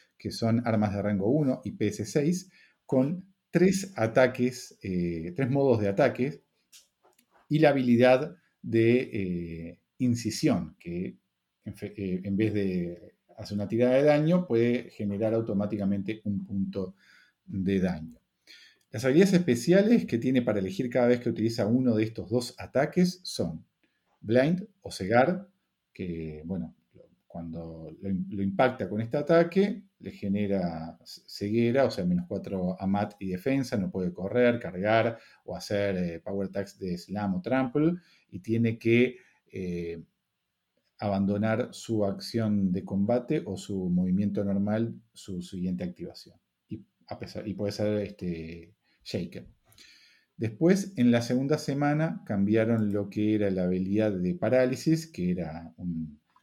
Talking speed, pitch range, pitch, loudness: 140 wpm, 95-130 Hz, 105 Hz, -28 LUFS